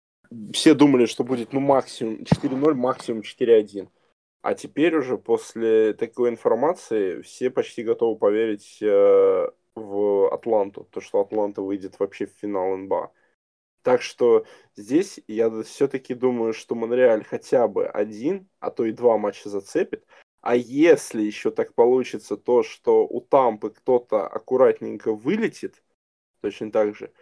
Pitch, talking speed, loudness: 155 Hz, 135 wpm, -22 LUFS